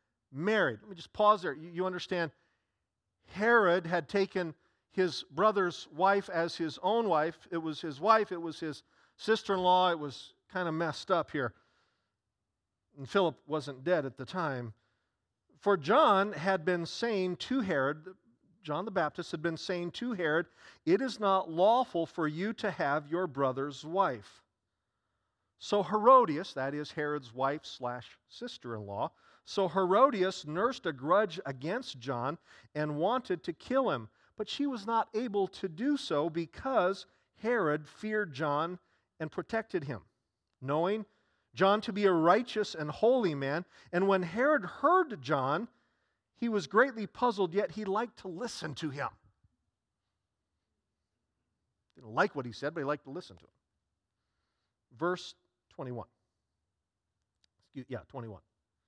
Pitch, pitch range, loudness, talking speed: 170 Hz, 140-200 Hz, -32 LUFS, 145 wpm